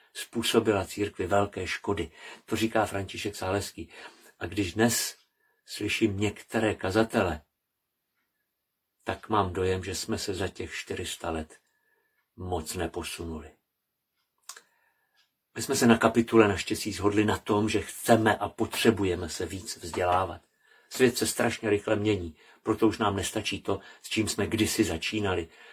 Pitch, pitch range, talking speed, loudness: 105 Hz, 95-110 Hz, 135 wpm, -28 LUFS